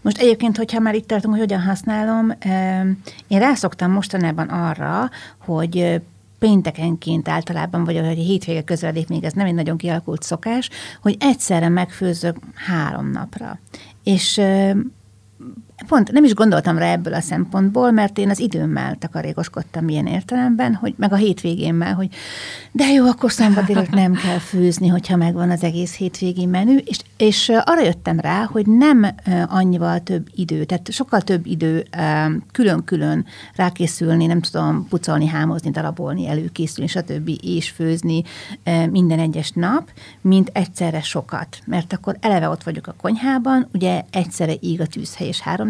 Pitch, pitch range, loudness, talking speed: 180 Hz, 165-210 Hz, -19 LUFS, 150 wpm